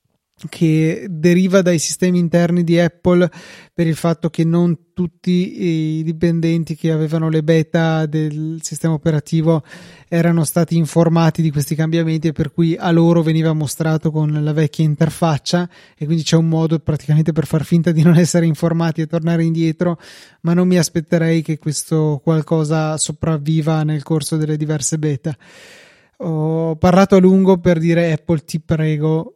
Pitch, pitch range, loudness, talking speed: 165 Hz, 160-170 Hz, -16 LUFS, 155 wpm